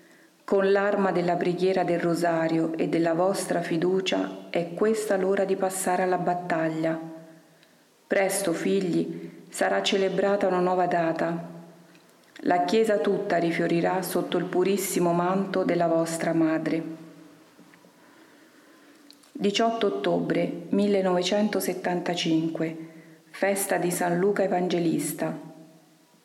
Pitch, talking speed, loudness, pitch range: 180 Hz, 100 wpm, -25 LUFS, 165-195 Hz